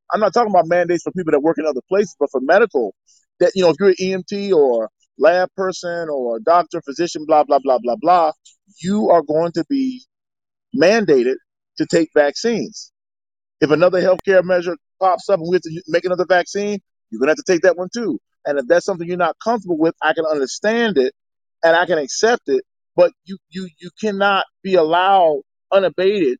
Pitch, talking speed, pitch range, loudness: 180 Hz, 200 wpm, 165-205 Hz, -17 LUFS